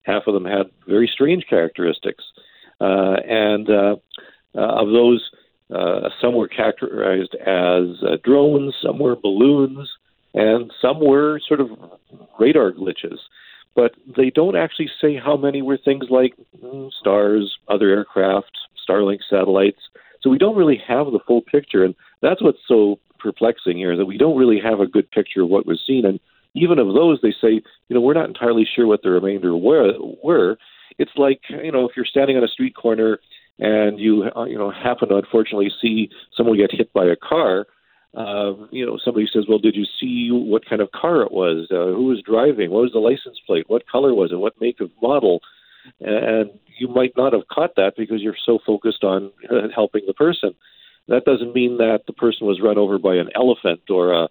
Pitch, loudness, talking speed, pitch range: 110 Hz, -18 LUFS, 195 wpm, 100-130 Hz